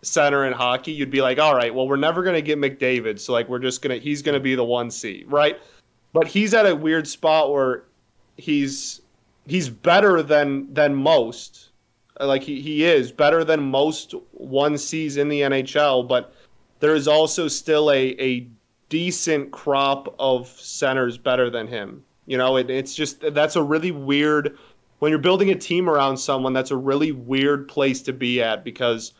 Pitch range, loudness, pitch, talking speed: 130-155 Hz, -20 LUFS, 140 Hz, 190 wpm